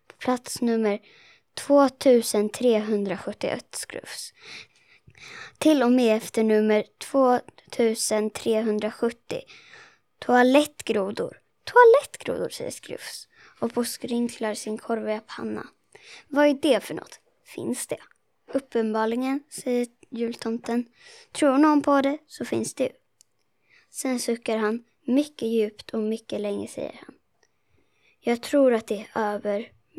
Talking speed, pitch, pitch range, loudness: 105 wpm, 240 Hz, 220-280 Hz, -24 LUFS